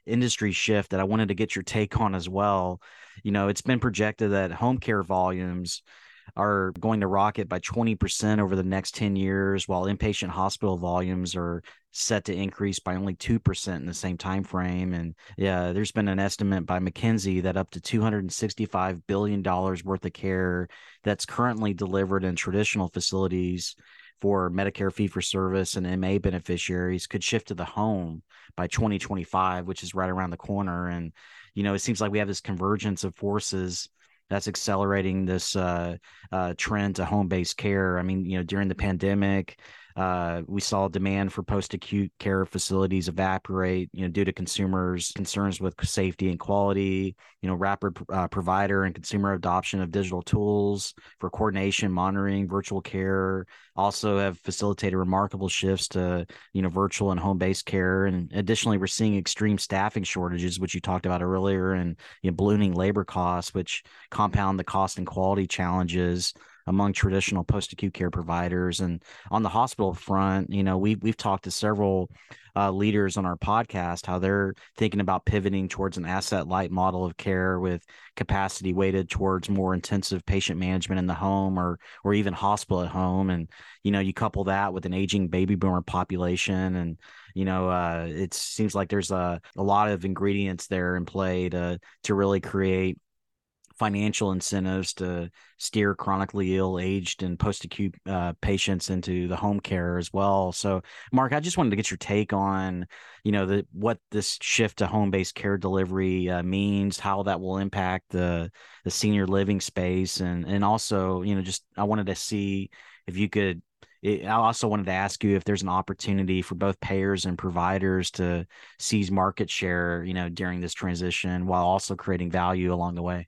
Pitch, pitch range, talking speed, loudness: 95 Hz, 90-100 Hz, 180 wpm, -27 LUFS